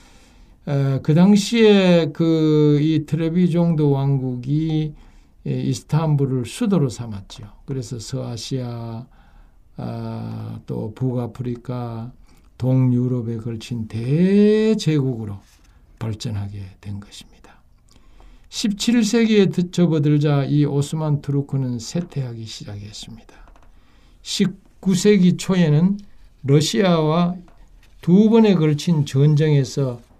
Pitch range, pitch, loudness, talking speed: 115-170 Hz, 140 Hz, -19 LUFS, 205 characters per minute